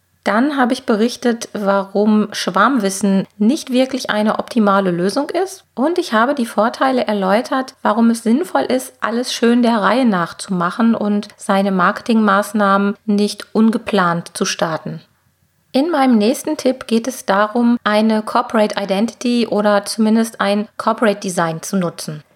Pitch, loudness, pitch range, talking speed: 220 Hz, -16 LUFS, 200-245 Hz, 140 wpm